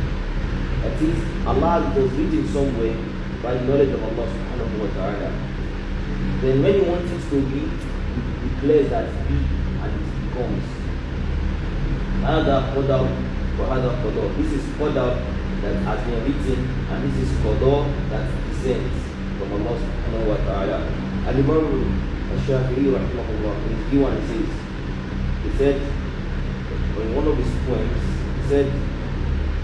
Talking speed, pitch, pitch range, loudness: 115 wpm, 65 Hz, 65-70 Hz, -23 LUFS